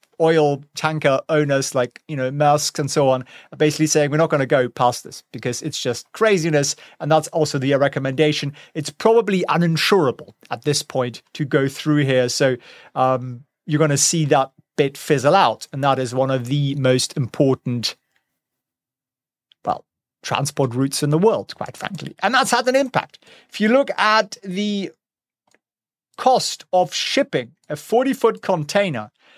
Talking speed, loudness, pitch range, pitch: 165 wpm, -19 LUFS, 135-175 Hz, 150 Hz